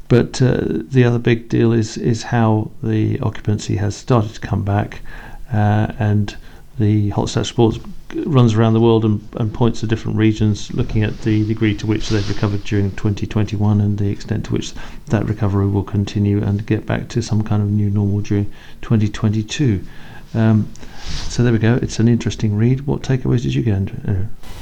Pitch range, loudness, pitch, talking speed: 105-115 Hz, -18 LUFS, 110 Hz, 190 wpm